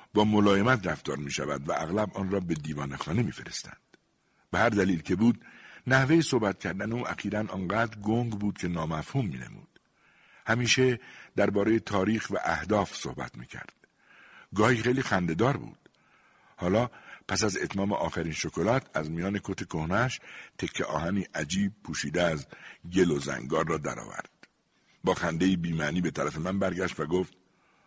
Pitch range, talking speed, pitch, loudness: 80-110 Hz, 155 wpm, 95 Hz, -29 LUFS